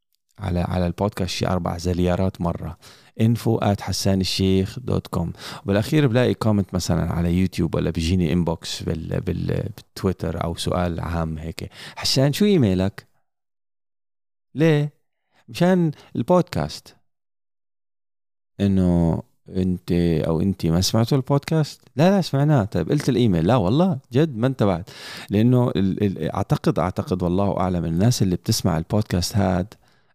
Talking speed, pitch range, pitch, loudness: 125 wpm, 90-125 Hz, 100 Hz, -22 LUFS